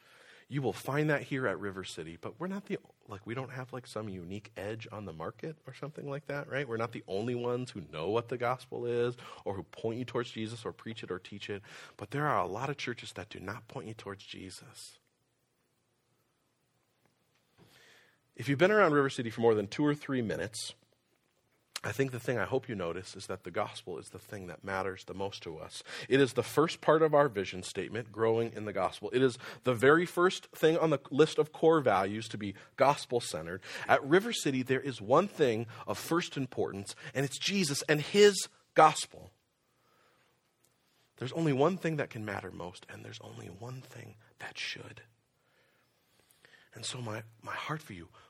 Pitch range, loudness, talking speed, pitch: 105-140 Hz, -32 LUFS, 205 wpm, 120 Hz